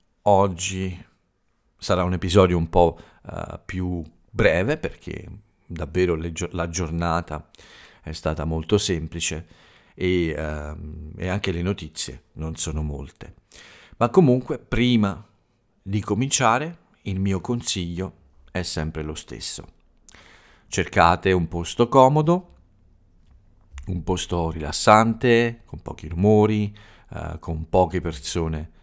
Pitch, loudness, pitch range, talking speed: 90 Hz, -22 LUFS, 80-105 Hz, 110 wpm